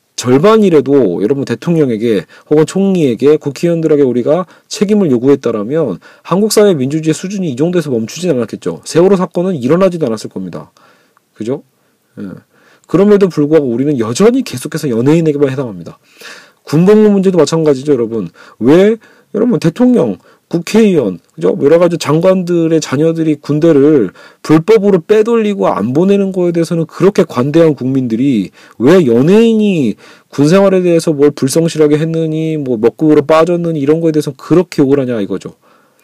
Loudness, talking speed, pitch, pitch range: -11 LUFS, 380 characters per minute, 160 Hz, 145-190 Hz